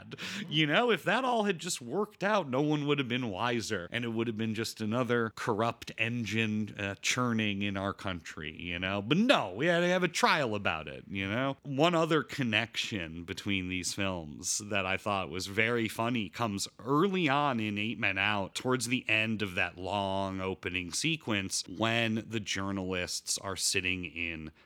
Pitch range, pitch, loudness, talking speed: 95-130 Hz, 110 Hz, -31 LUFS, 185 wpm